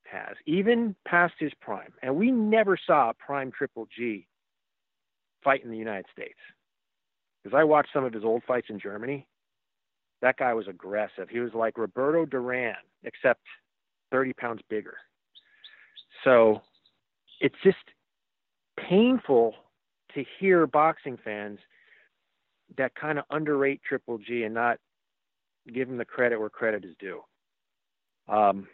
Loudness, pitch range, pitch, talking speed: -27 LUFS, 115-155 Hz, 130 Hz, 140 wpm